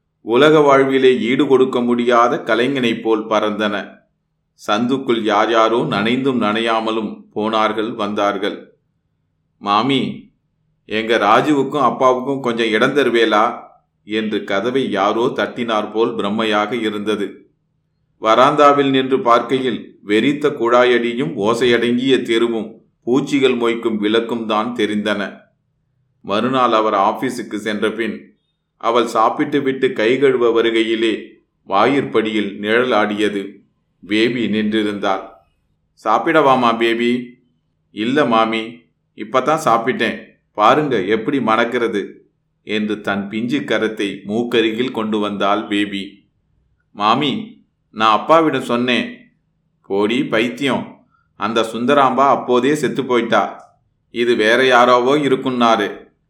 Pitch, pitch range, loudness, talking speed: 115 Hz, 110-130 Hz, -16 LUFS, 95 wpm